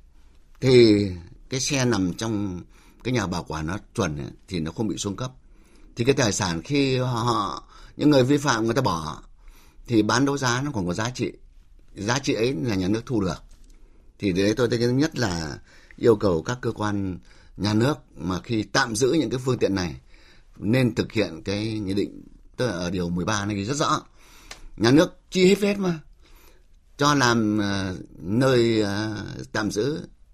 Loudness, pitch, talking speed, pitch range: -24 LUFS, 110 Hz, 190 wpm, 95-125 Hz